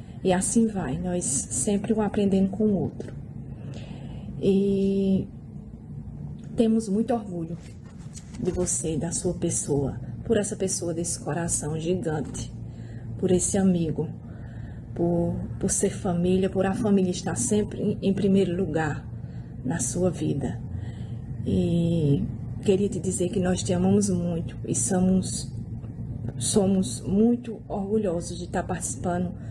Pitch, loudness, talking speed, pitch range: 175 Hz, -26 LUFS, 120 wpm, 125-195 Hz